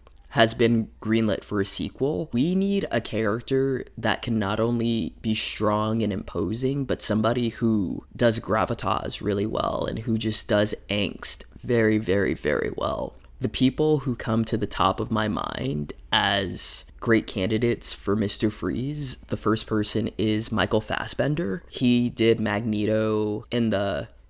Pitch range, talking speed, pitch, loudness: 105-115 Hz, 150 wpm, 110 Hz, -25 LUFS